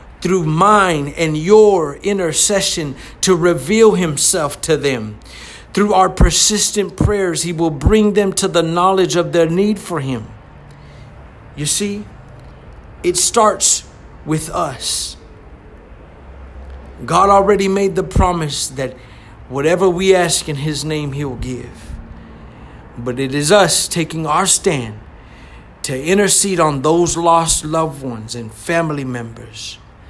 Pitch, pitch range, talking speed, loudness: 160 Hz, 120-190 Hz, 125 wpm, -14 LUFS